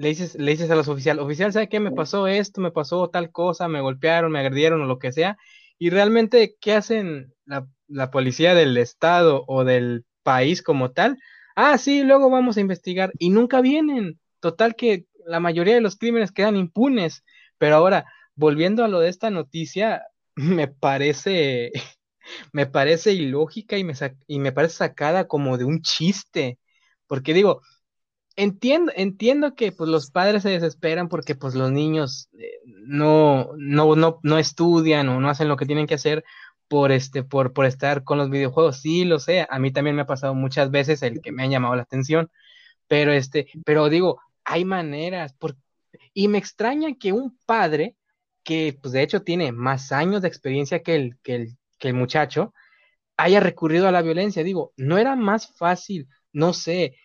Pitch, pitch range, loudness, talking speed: 165 Hz, 145-200 Hz, -21 LUFS, 185 wpm